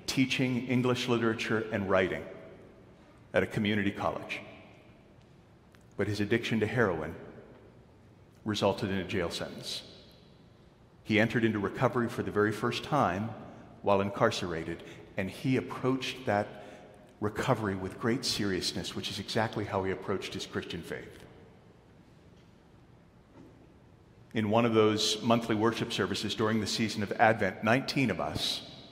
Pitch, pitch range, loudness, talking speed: 110 Hz, 100-115 Hz, -31 LUFS, 130 wpm